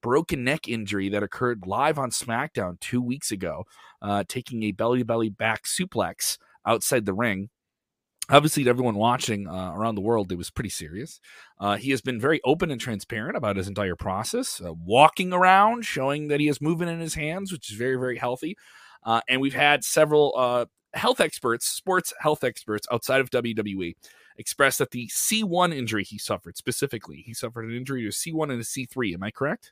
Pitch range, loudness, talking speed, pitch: 105-145 Hz, -25 LUFS, 195 wpm, 120 Hz